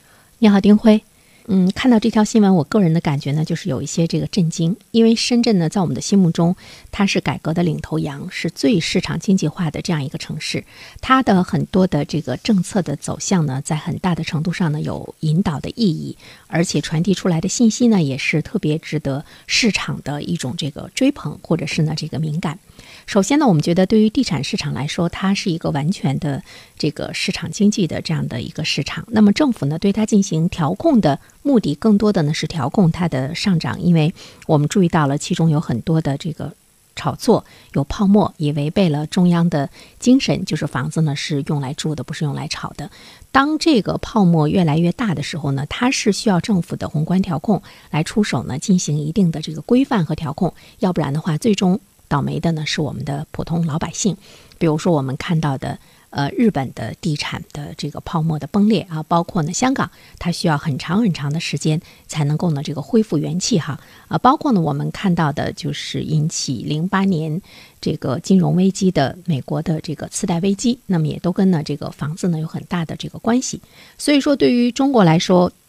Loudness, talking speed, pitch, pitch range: -18 LUFS, 315 characters per minute, 170 Hz, 155-200 Hz